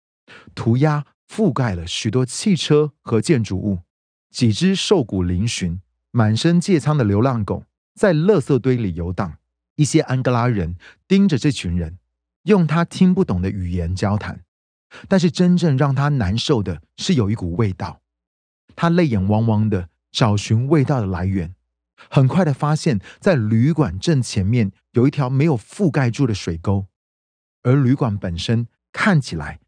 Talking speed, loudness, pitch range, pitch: 230 characters per minute, -19 LUFS, 95-150 Hz, 115 Hz